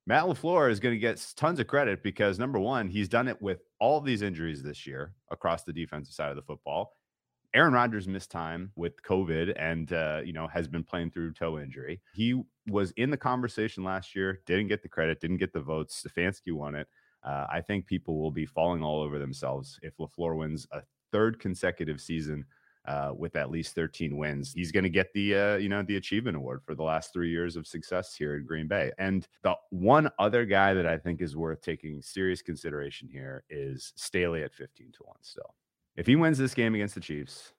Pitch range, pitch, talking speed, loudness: 80-100 Hz, 85 Hz, 215 wpm, -30 LUFS